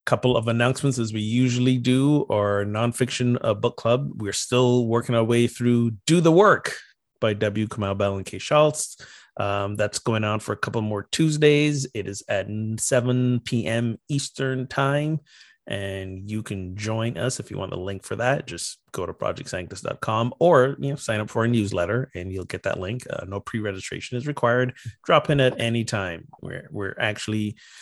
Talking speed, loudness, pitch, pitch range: 190 wpm, -24 LUFS, 115 Hz, 105-125 Hz